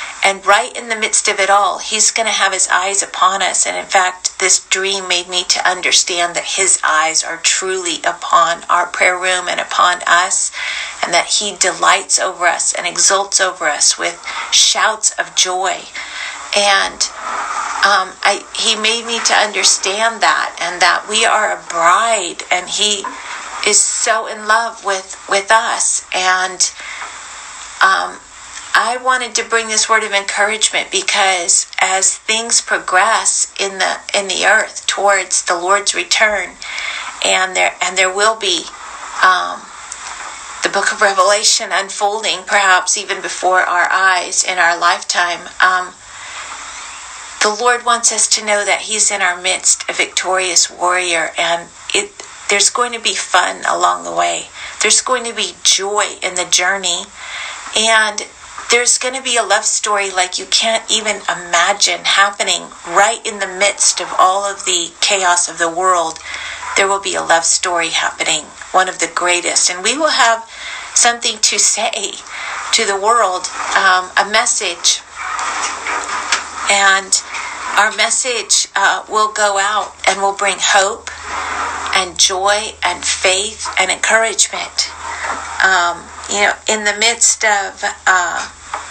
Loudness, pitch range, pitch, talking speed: -13 LUFS, 185-220 Hz, 200 Hz, 150 wpm